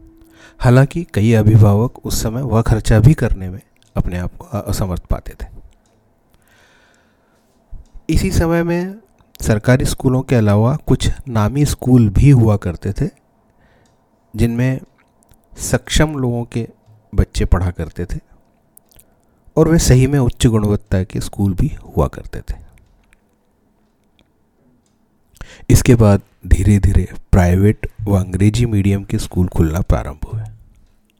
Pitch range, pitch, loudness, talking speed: 100-125 Hz, 110 Hz, -16 LUFS, 120 wpm